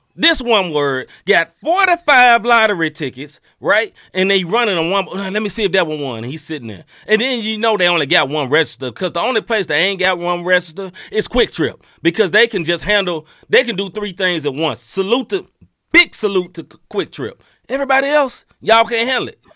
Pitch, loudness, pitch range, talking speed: 195 Hz, -16 LUFS, 170-230 Hz, 220 wpm